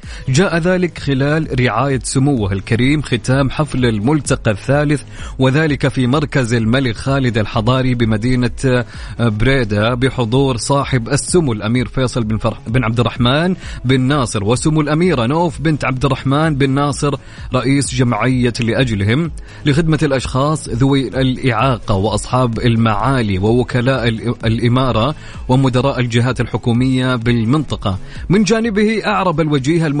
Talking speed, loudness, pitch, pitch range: 115 wpm, -15 LUFS, 130 Hz, 120-145 Hz